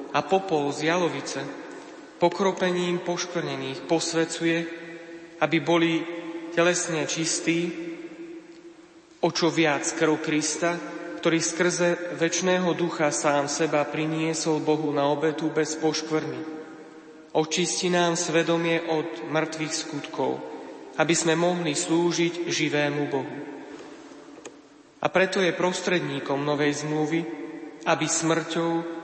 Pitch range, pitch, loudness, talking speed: 155-170 Hz, 165 Hz, -25 LUFS, 100 wpm